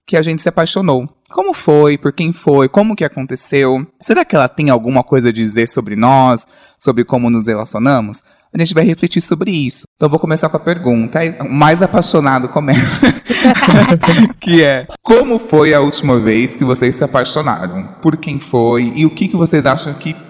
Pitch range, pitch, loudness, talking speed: 130-170 Hz, 150 Hz, -12 LUFS, 195 wpm